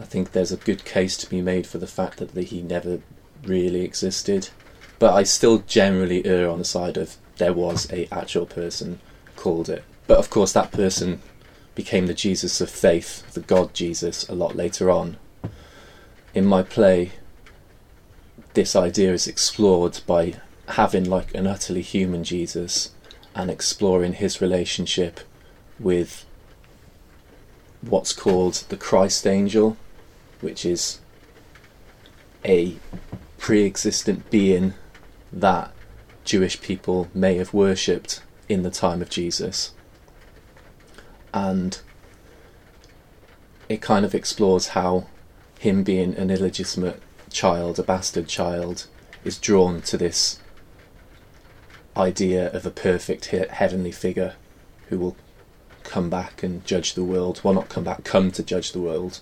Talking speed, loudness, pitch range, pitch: 135 wpm, -22 LUFS, 90-95 Hz, 90 Hz